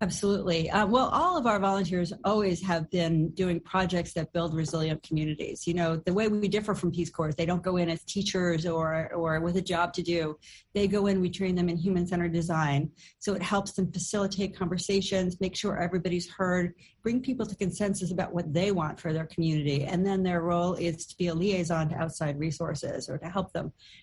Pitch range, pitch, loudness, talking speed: 165-195 Hz, 175 Hz, -29 LUFS, 210 wpm